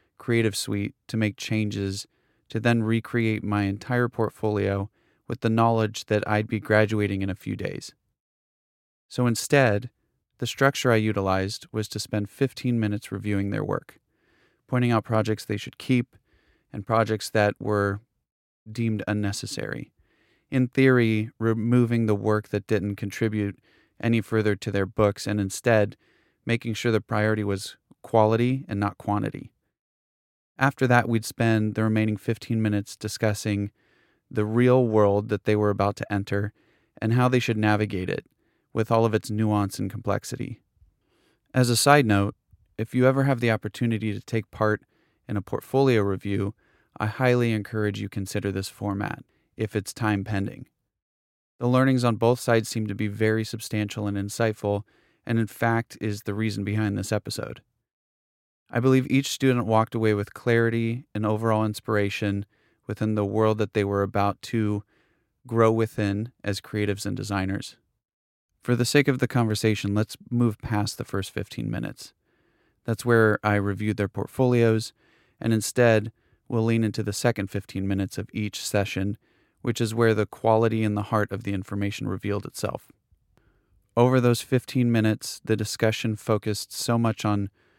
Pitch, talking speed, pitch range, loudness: 110 Hz, 160 wpm, 100-115 Hz, -25 LUFS